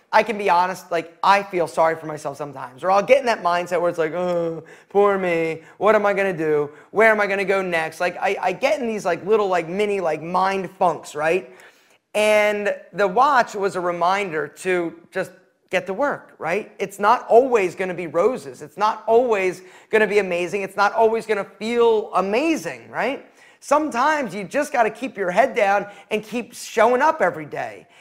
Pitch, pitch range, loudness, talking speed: 195 Hz, 175-220 Hz, -20 LUFS, 210 wpm